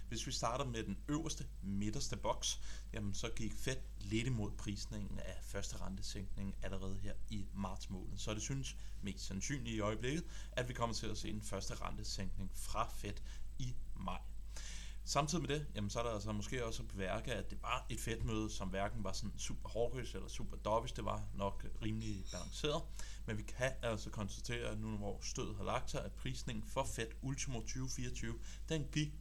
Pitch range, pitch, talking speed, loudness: 100-120 Hz, 110 Hz, 190 wpm, -43 LUFS